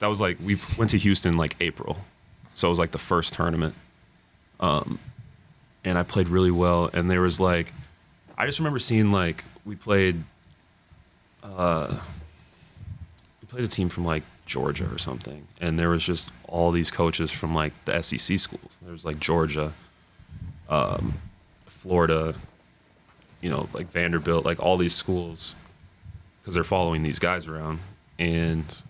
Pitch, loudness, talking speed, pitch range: 85 Hz, -25 LUFS, 160 wpm, 80-90 Hz